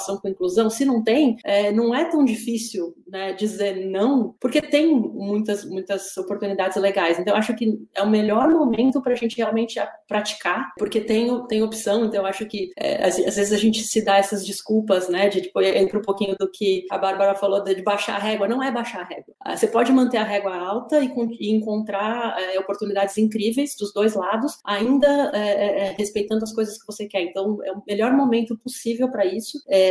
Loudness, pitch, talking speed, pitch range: -22 LUFS, 210 Hz, 205 wpm, 195-230 Hz